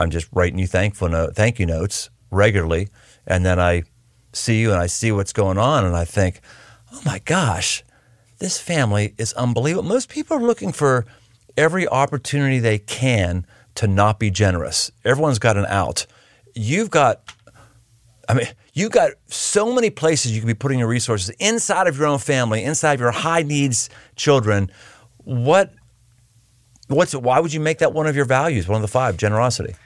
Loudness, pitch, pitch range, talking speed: -19 LUFS, 120 Hz, 105-145 Hz, 185 wpm